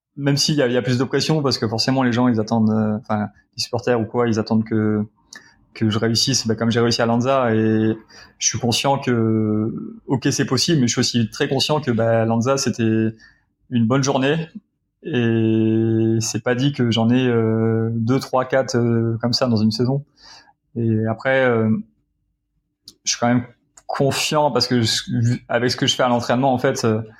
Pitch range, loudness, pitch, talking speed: 110-135 Hz, -19 LUFS, 120 Hz, 200 wpm